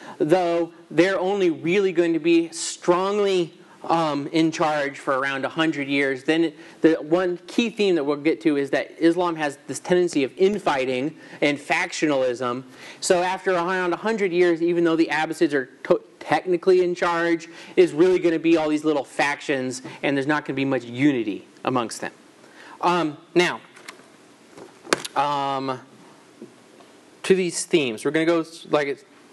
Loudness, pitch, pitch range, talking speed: -22 LUFS, 165 Hz, 145-180 Hz, 160 wpm